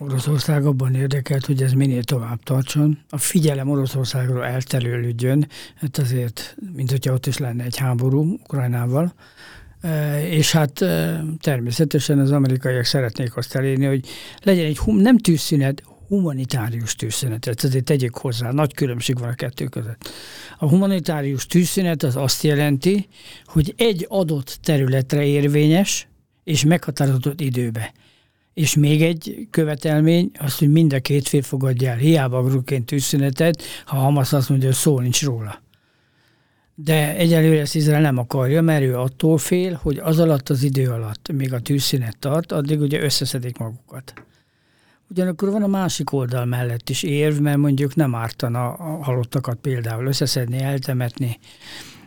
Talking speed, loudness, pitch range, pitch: 150 wpm, -20 LUFS, 130-155 Hz, 140 Hz